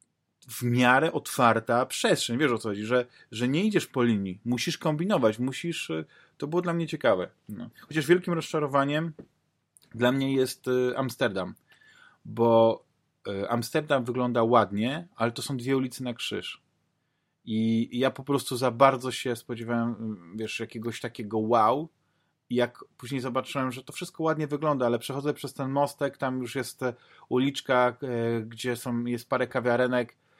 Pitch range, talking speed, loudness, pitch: 120-140 Hz, 150 wpm, -27 LUFS, 125 Hz